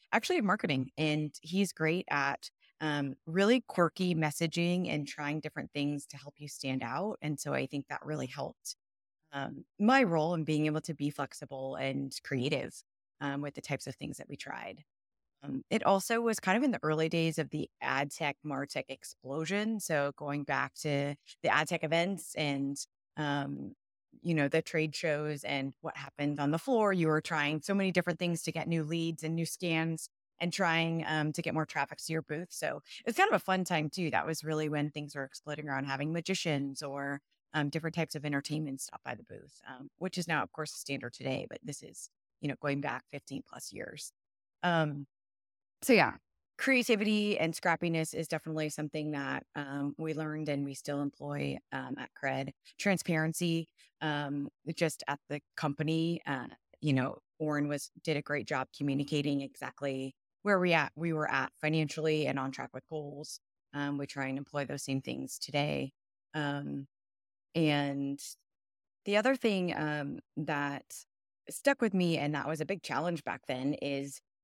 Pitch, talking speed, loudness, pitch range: 150 Hz, 185 wpm, -34 LUFS, 140-165 Hz